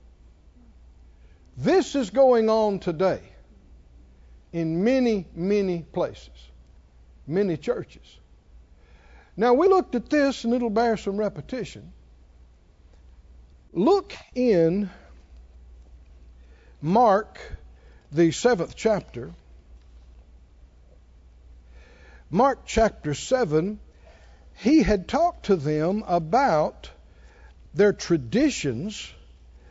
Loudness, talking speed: -23 LUFS, 75 wpm